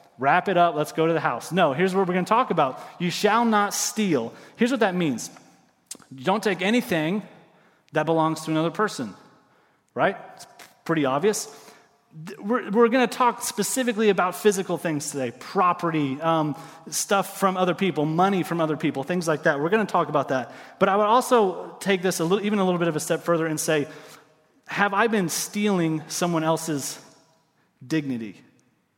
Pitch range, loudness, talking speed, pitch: 160-205 Hz, -23 LUFS, 190 wpm, 175 Hz